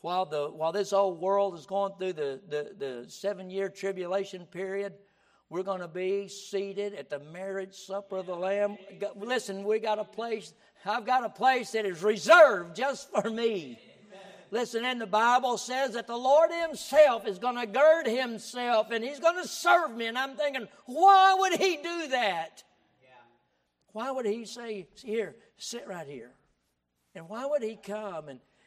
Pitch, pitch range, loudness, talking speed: 205 Hz, 190-245 Hz, -28 LUFS, 180 wpm